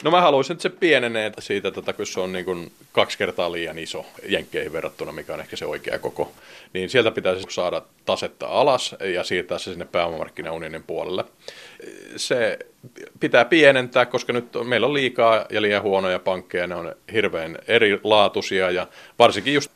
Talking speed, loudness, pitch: 170 wpm, -22 LUFS, 140 Hz